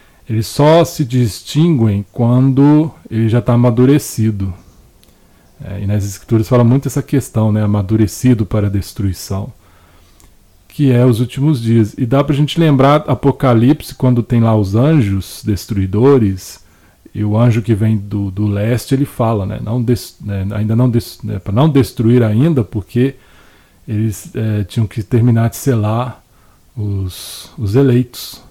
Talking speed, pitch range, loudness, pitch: 145 wpm, 100-130 Hz, -14 LUFS, 115 Hz